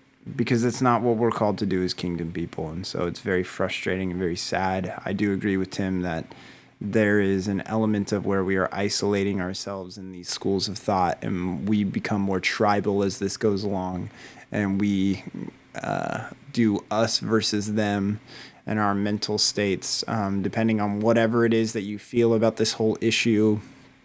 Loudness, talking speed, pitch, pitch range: -25 LUFS, 180 wpm, 100 Hz, 95-110 Hz